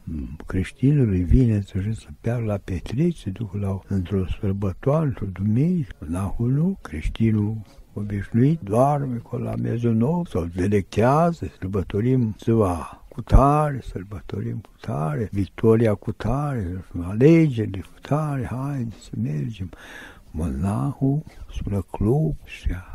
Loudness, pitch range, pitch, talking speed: -23 LUFS, 95-130 Hz, 110 Hz, 110 wpm